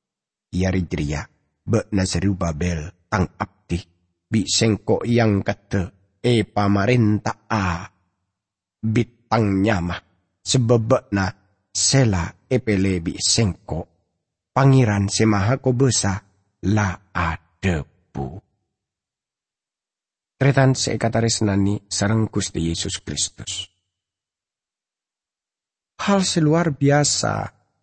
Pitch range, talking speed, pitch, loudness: 95-115 Hz, 80 wpm, 100 Hz, -21 LUFS